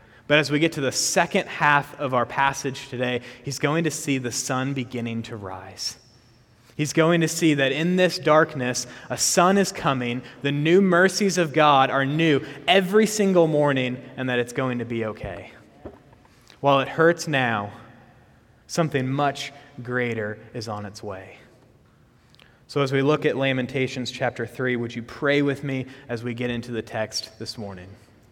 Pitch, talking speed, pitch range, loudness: 130 Hz, 175 wpm, 120-145 Hz, -23 LUFS